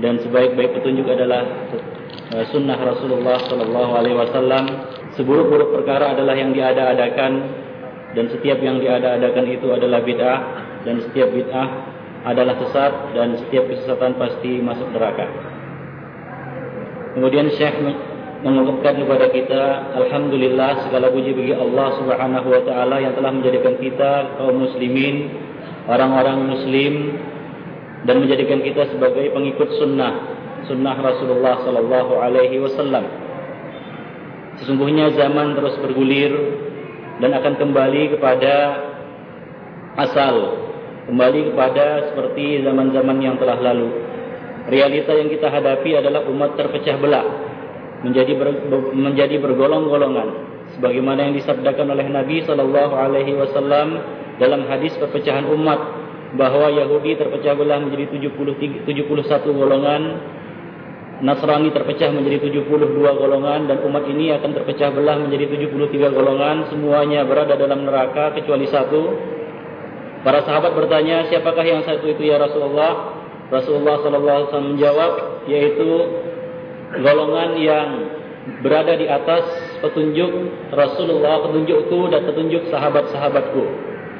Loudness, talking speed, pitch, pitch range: -17 LUFS, 115 wpm, 140 Hz, 130-150 Hz